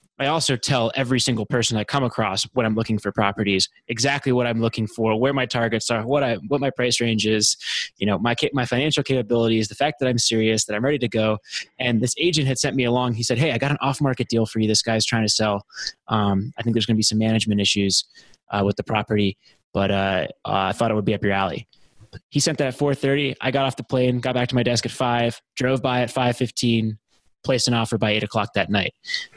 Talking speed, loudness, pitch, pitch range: 245 wpm, -21 LUFS, 120 Hz, 110-130 Hz